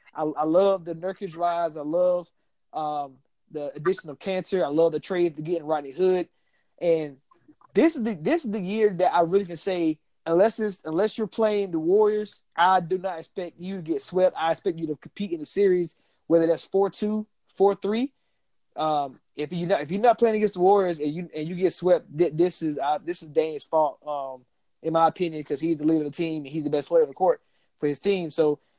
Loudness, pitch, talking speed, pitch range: -25 LUFS, 175 Hz, 230 wpm, 155-195 Hz